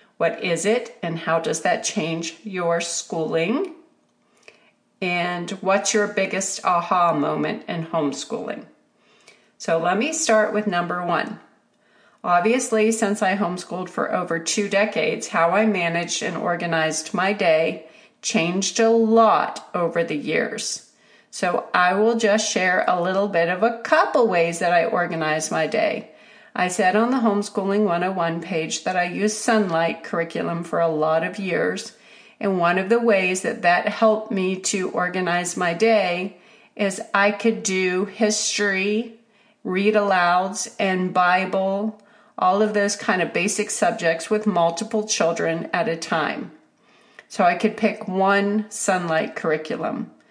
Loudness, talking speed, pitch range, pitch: -21 LUFS, 145 wpm, 175-220 Hz, 195 Hz